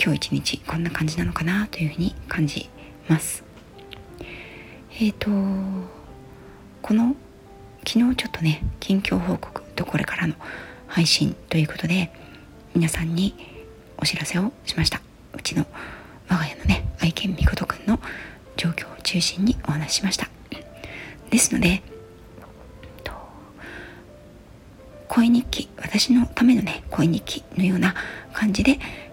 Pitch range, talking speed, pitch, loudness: 150-210 Hz, 240 characters per minute, 175 Hz, -23 LUFS